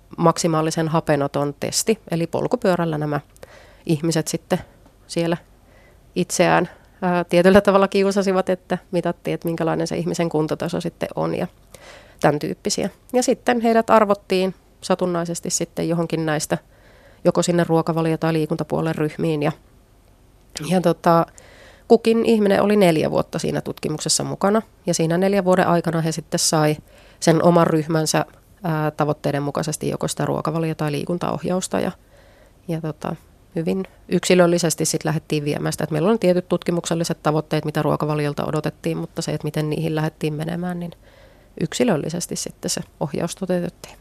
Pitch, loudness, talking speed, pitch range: 165 Hz, -21 LUFS, 135 wpm, 155-180 Hz